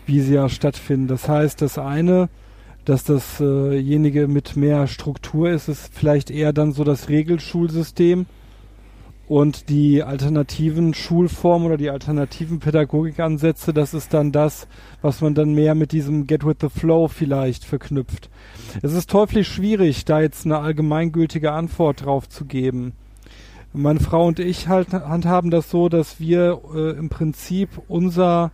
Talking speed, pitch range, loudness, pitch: 145 wpm, 140-165 Hz, -19 LUFS, 150 Hz